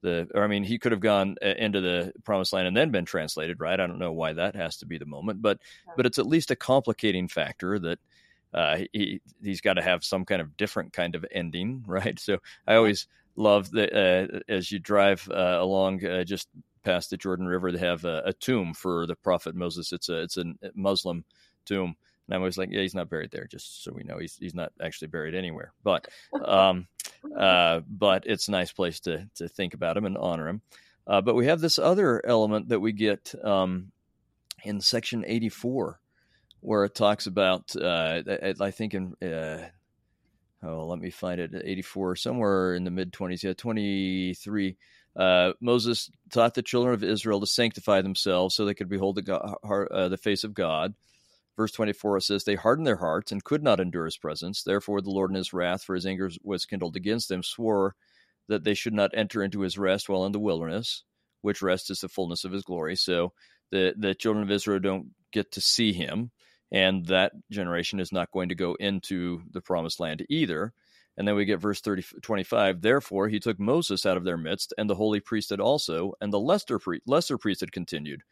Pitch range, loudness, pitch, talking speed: 90-105 Hz, -27 LUFS, 95 Hz, 205 wpm